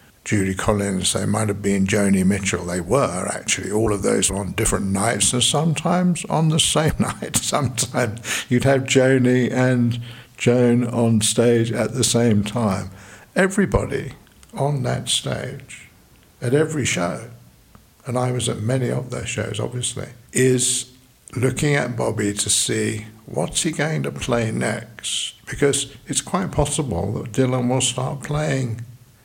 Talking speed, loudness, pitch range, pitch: 150 wpm, -20 LUFS, 110-130 Hz, 120 Hz